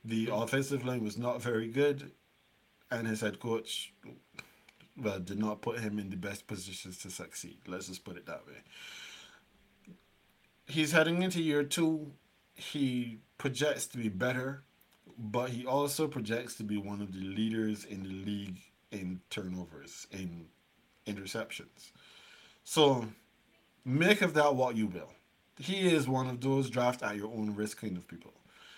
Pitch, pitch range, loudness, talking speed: 115 Hz, 105-140 Hz, -34 LUFS, 155 wpm